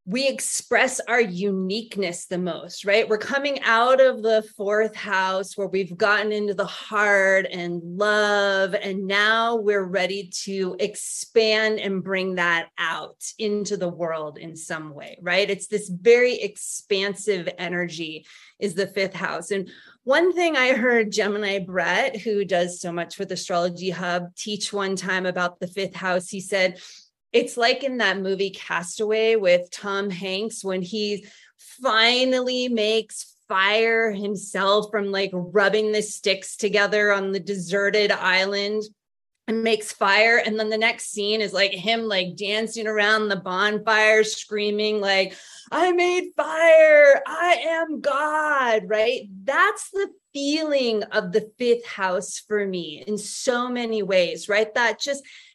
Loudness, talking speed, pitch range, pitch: -22 LUFS, 150 wpm, 190-225 Hz, 205 Hz